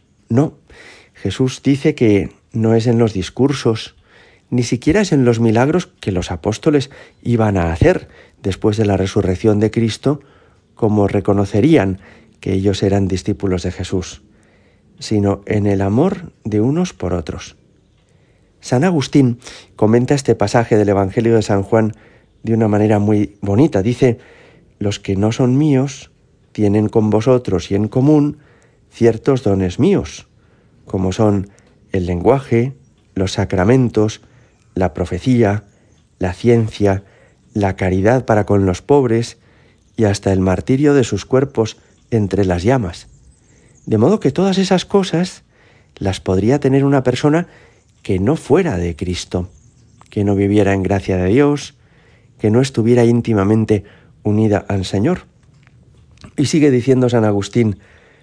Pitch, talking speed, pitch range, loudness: 110 Hz, 140 wpm, 100-125 Hz, -16 LUFS